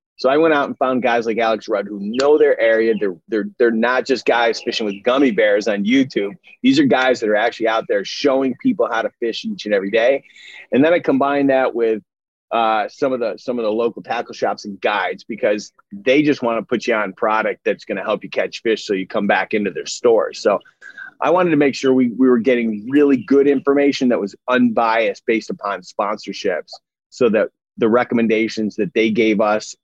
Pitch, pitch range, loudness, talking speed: 125 Hz, 110-150 Hz, -18 LUFS, 225 wpm